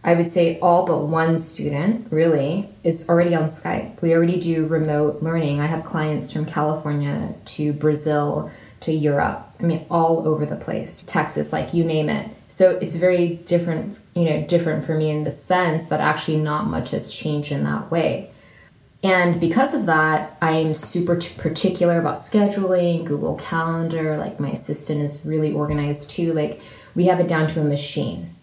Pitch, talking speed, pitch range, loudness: 160 Hz, 175 wpm, 150-170 Hz, -21 LUFS